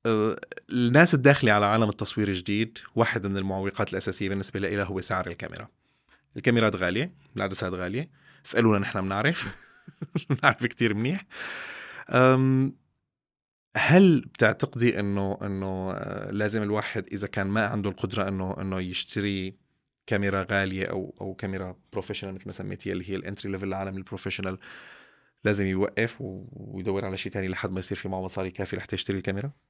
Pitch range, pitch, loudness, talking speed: 95-115 Hz, 100 Hz, -27 LUFS, 140 wpm